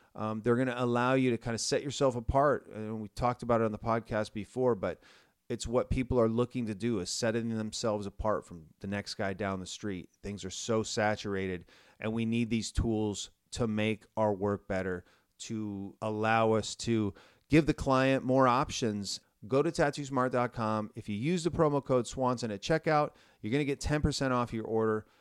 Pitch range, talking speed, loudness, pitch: 105-125 Hz, 200 wpm, -32 LUFS, 110 Hz